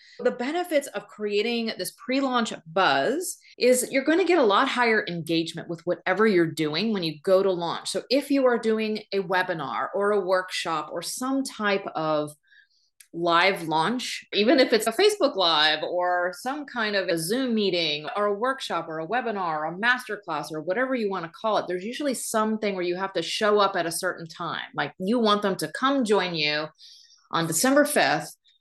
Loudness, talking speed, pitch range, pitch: -24 LUFS, 200 wpm, 175-250 Hz, 205 Hz